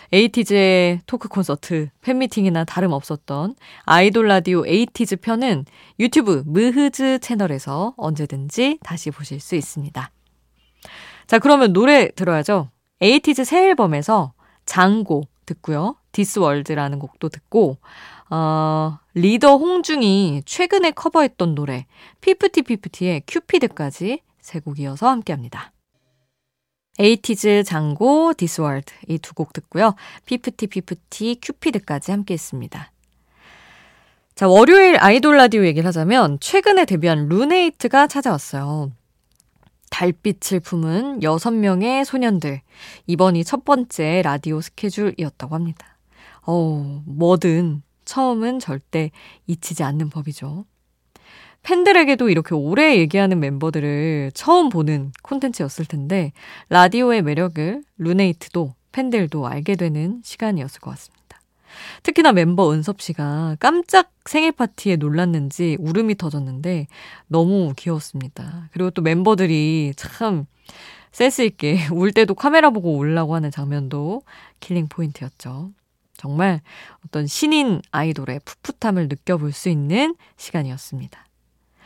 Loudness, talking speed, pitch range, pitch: -18 LUFS, 290 characters per minute, 150-225 Hz, 175 Hz